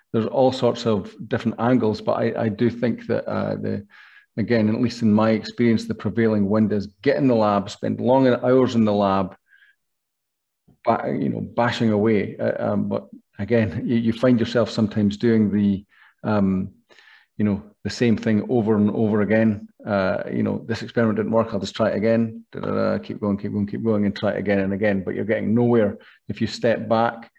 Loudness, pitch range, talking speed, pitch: -22 LUFS, 105-115 Hz, 205 wpm, 110 Hz